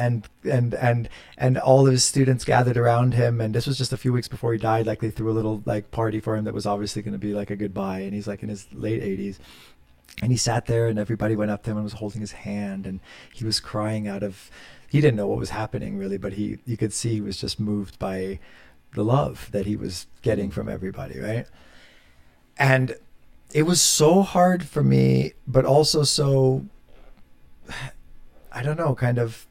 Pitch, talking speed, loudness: 105 Hz, 220 wpm, -23 LUFS